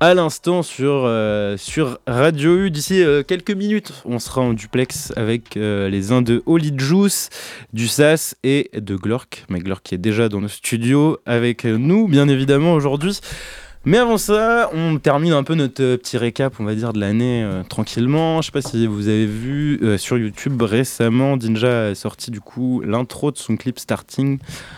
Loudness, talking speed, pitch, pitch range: -18 LUFS, 195 wpm, 125 Hz, 115-150 Hz